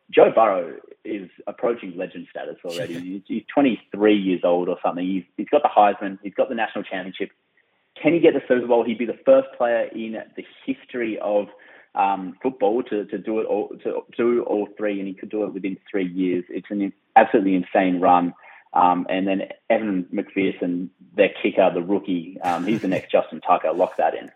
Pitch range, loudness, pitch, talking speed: 95-115 Hz, -22 LUFS, 105 Hz, 195 wpm